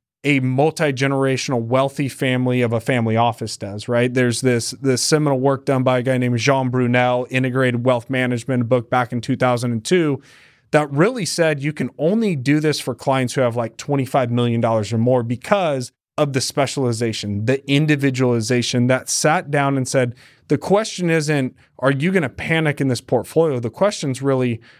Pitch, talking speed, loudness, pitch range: 130 Hz, 175 wpm, -19 LUFS, 125-140 Hz